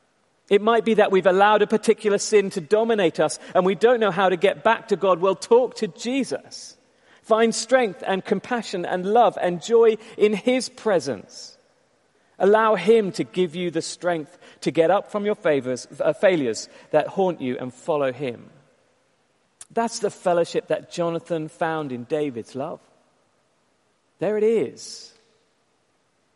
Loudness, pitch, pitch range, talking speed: -22 LUFS, 195 Hz, 170-220 Hz, 160 wpm